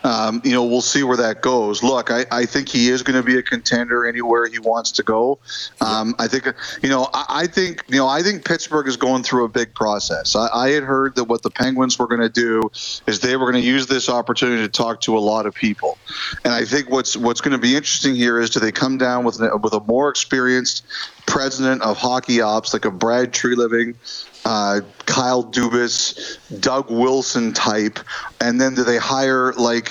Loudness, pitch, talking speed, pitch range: -18 LUFS, 125 Hz, 225 wpm, 115-130 Hz